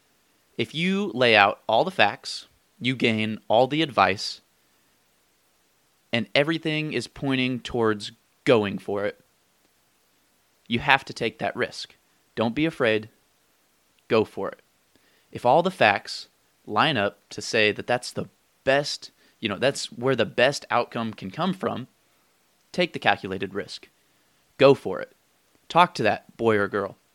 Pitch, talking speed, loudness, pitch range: 125 Hz, 150 wpm, -24 LUFS, 110-145 Hz